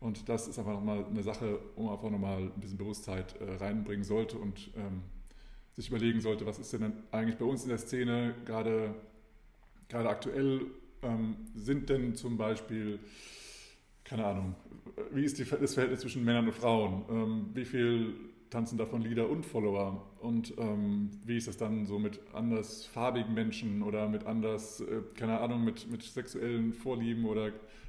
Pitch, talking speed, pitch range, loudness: 110 Hz, 170 wpm, 105-115 Hz, -35 LUFS